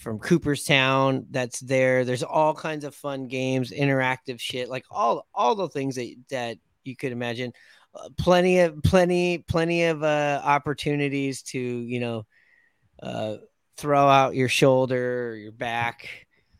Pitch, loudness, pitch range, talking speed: 135 Hz, -24 LUFS, 125-145 Hz, 150 wpm